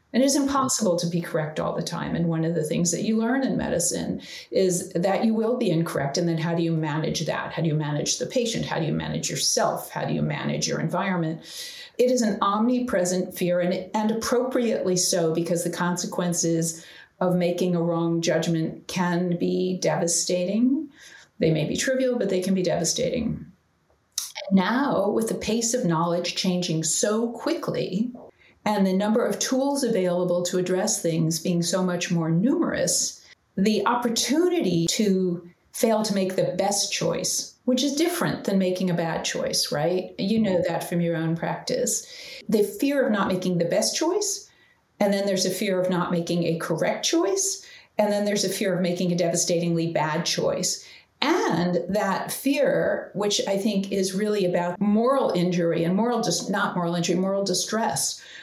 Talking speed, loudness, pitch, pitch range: 180 wpm, -24 LUFS, 185 Hz, 175-230 Hz